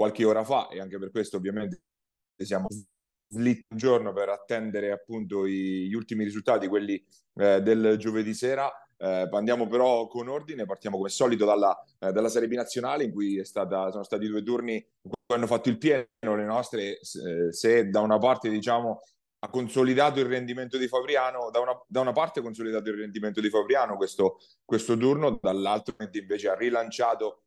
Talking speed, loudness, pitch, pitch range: 180 wpm, -27 LUFS, 110 Hz, 105-125 Hz